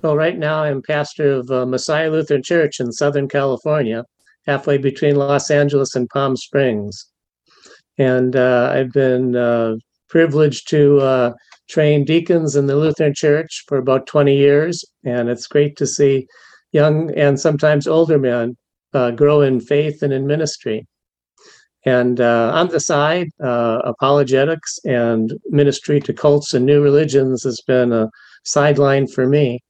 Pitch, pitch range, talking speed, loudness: 140 Hz, 125-150 Hz, 150 wpm, -16 LUFS